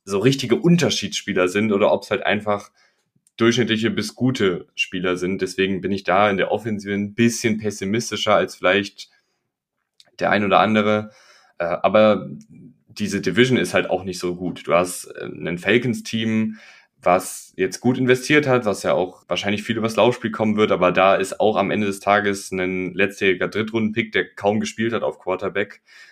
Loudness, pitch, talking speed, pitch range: -20 LUFS, 105 Hz, 170 wpm, 100-115 Hz